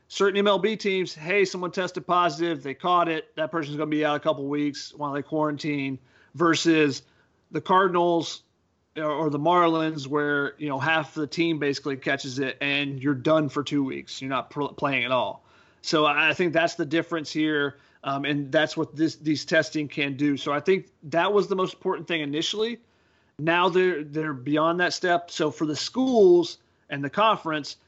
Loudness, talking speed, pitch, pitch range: -25 LUFS, 185 wpm, 155 Hz, 145-175 Hz